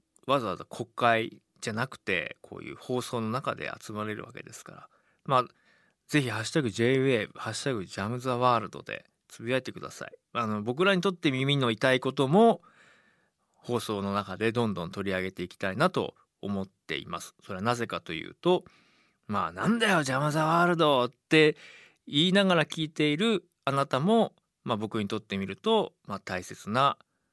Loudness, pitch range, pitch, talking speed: -28 LUFS, 110-160 Hz, 125 Hz, 360 characters per minute